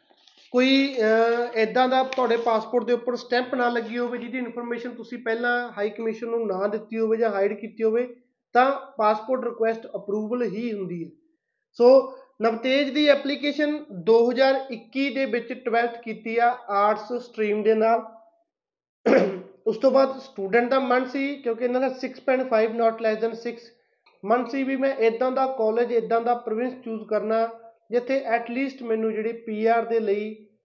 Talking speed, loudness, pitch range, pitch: 160 wpm, -24 LUFS, 225-260 Hz, 235 Hz